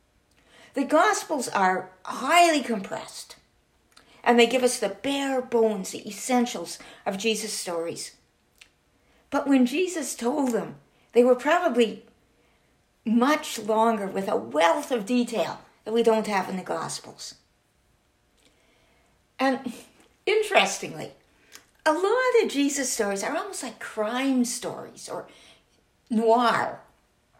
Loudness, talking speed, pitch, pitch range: -25 LUFS, 115 wpm, 240 Hz, 220-280 Hz